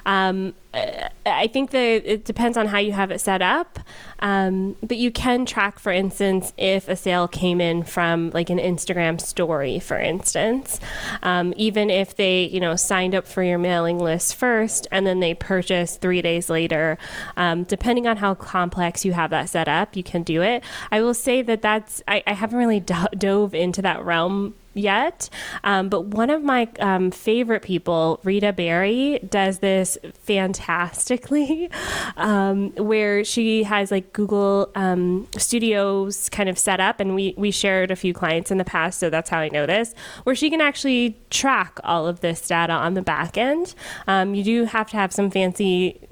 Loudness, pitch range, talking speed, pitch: -21 LUFS, 180-220 Hz, 185 wpm, 195 Hz